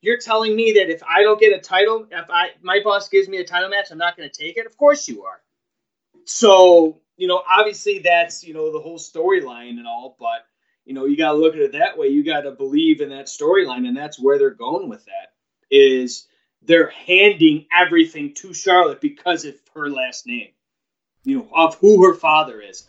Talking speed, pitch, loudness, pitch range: 225 wpm, 185 Hz, -16 LUFS, 160-225 Hz